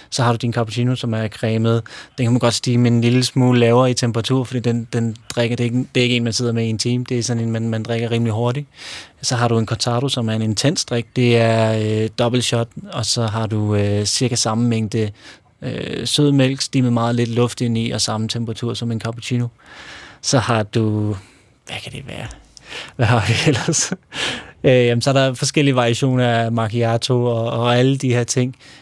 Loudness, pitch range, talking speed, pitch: -18 LUFS, 115-125 Hz, 230 wpm, 120 Hz